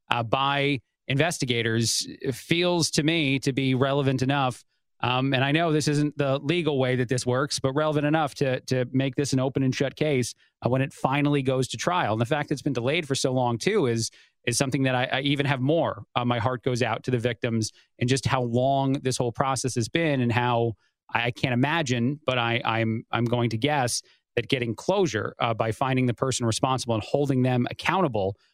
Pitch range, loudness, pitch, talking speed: 120-140 Hz, -25 LUFS, 130 Hz, 220 wpm